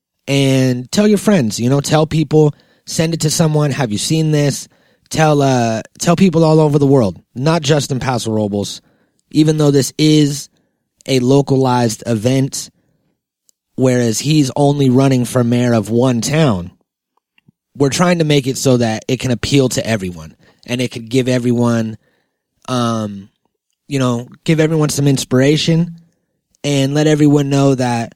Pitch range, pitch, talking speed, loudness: 120-155 Hz, 135 Hz, 160 wpm, -14 LUFS